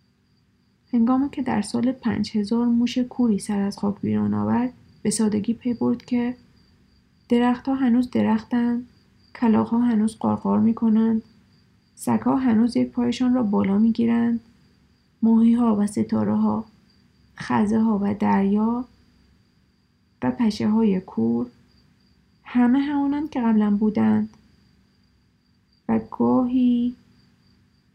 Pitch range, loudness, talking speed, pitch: 210-245 Hz, -22 LUFS, 120 wpm, 230 Hz